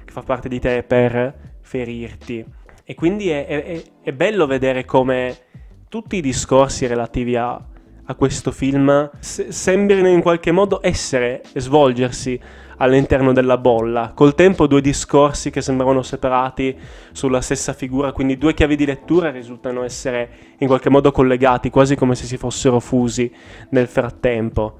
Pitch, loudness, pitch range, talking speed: 130 Hz, -17 LUFS, 125-140 Hz, 150 wpm